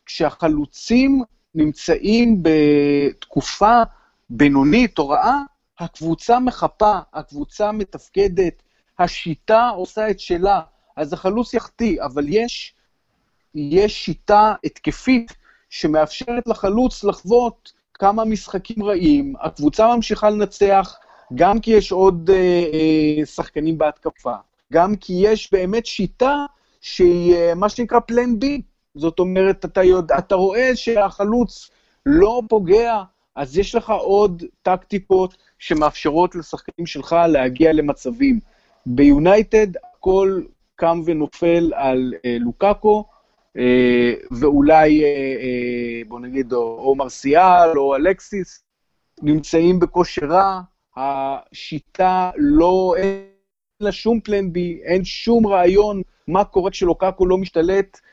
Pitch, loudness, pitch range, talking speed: 185 Hz, -17 LUFS, 155-215 Hz, 105 wpm